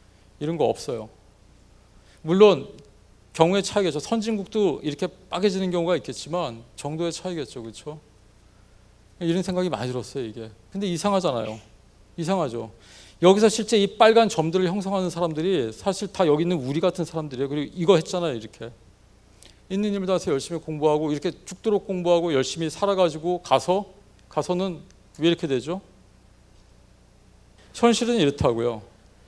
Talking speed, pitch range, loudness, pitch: 340 characters per minute, 115-185 Hz, -24 LUFS, 160 Hz